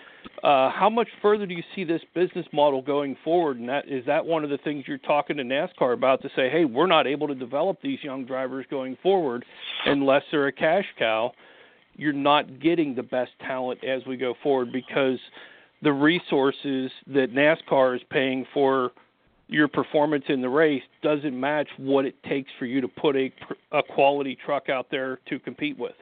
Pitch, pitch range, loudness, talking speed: 140 Hz, 130-155 Hz, -25 LUFS, 195 wpm